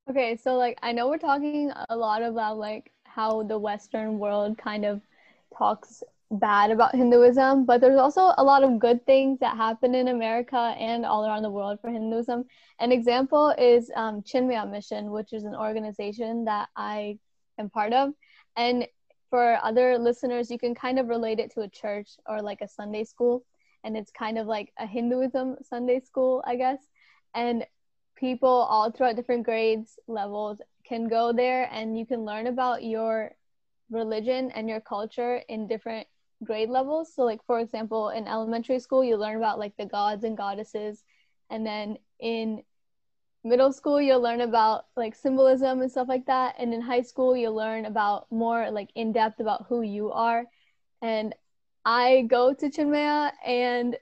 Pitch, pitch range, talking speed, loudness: 235 Hz, 220-255 Hz, 175 wpm, -26 LUFS